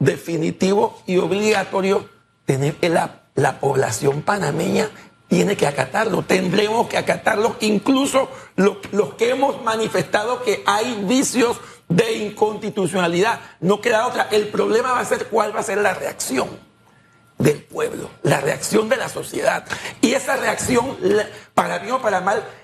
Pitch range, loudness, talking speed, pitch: 180-225 Hz, -20 LUFS, 145 wpm, 205 Hz